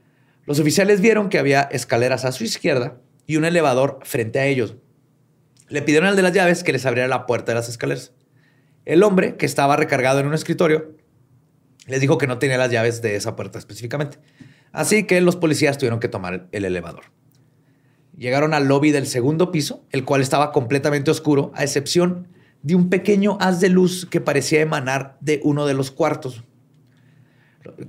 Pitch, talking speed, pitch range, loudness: 145 Hz, 180 wpm, 130-155 Hz, -19 LUFS